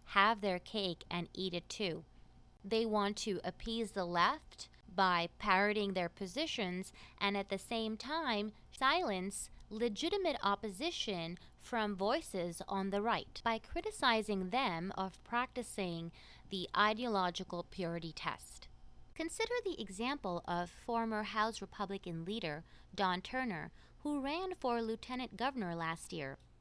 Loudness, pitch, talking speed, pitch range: -38 LUFS, 205 Hz, 125 wpm, 185-235 Hz